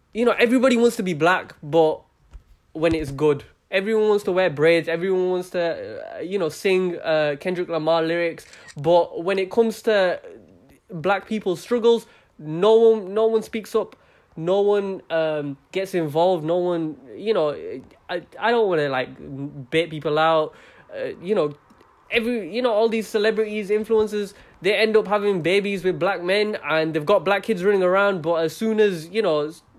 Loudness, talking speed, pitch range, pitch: -21 LUFS, 180 wpm, 165-220 Hz, 190 Hz